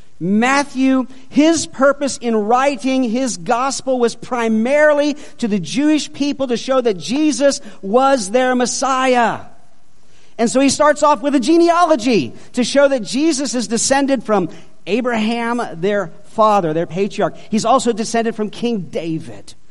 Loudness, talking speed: -16 LUFS, 140 wpm